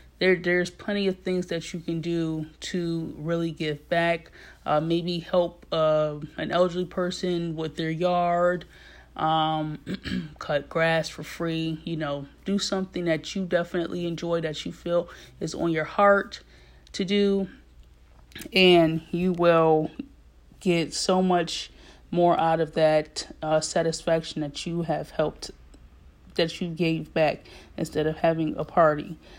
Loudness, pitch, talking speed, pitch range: -26 LUFS, 165 Hz, 145 wpm, 155-175 Hz